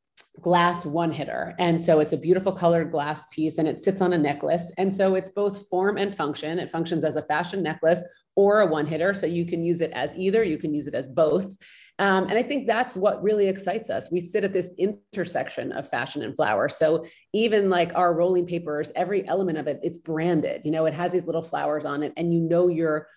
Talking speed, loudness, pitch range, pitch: 235 wpm, -24 LUFS, 160-190 Hz, 175 Hz